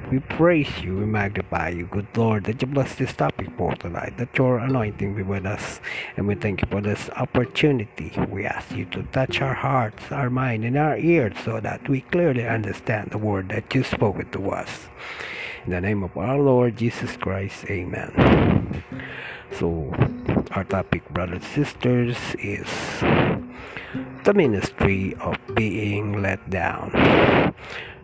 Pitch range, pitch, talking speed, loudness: 100-130 Hz, 110 Hz, 160 wpm, -23 LUFS